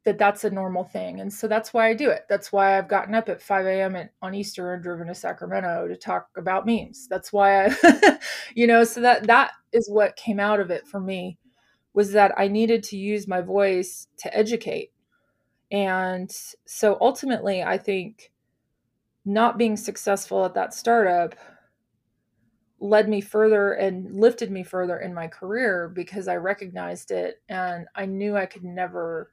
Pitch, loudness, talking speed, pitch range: 200 Hz, -23 LUFS, 180 wpm, 185-220 Hz